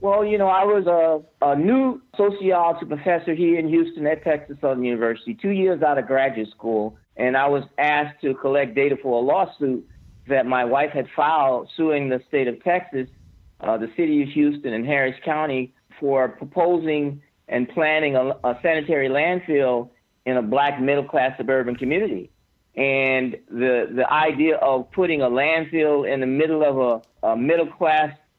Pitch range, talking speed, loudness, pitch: 130-160 Hz, 175 wpm, -21 LUFS, 140 Hz